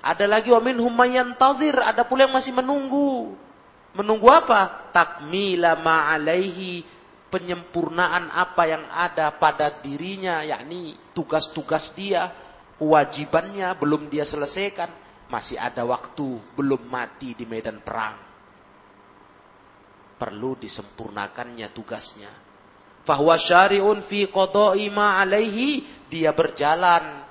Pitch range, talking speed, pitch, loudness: 130-195 Hz, 100 wpm, 165 Hz, -21 LUFS